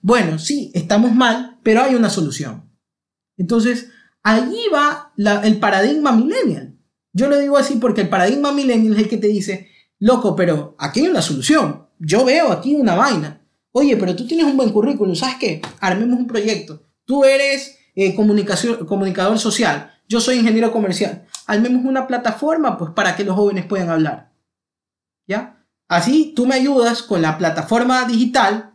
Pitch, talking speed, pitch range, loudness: 225 Hz, 165 wpm, 195-255 Hz, -17 LUFS